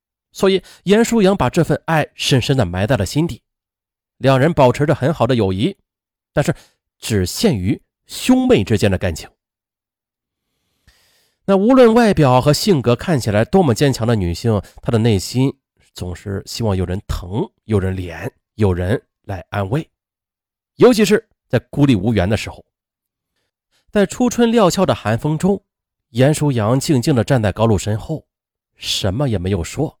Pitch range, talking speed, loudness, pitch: 100-155 Hz, 230 characters per minute, -16 LUFS, 120 Hz